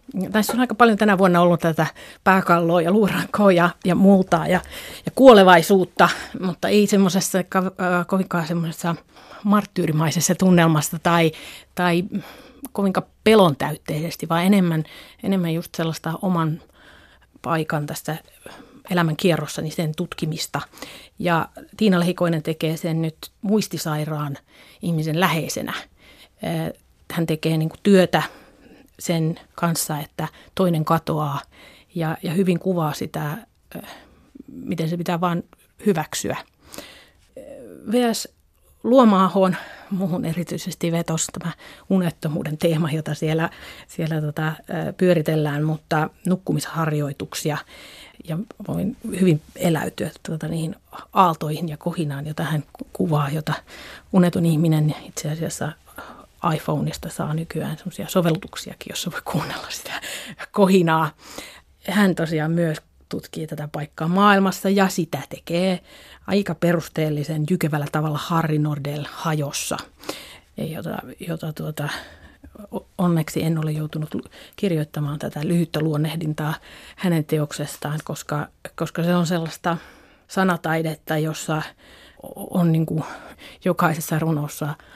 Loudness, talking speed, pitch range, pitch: -21 LUFS, 105 wpm, 155-185 Hz, 170 Hz